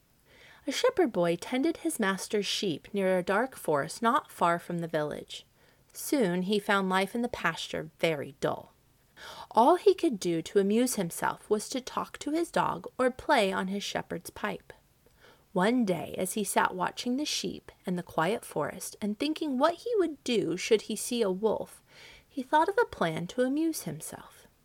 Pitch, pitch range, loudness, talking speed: 225 Hz, 190-295 Hz, -29 LUFS, 185 wpm